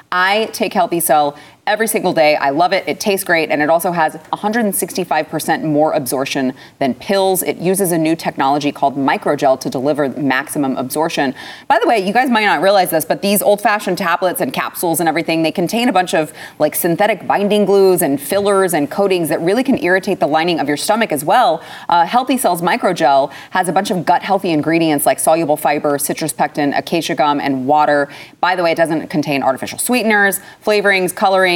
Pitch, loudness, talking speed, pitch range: 175 Hz, -15 LUFS, 195 wpm, 155-195 Hz